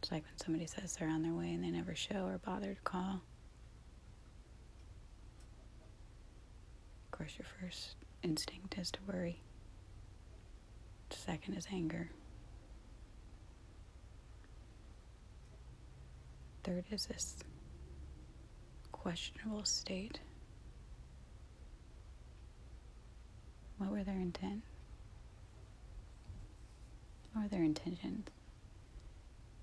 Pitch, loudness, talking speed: 105 Hz, -43 LUFS, 85 wpm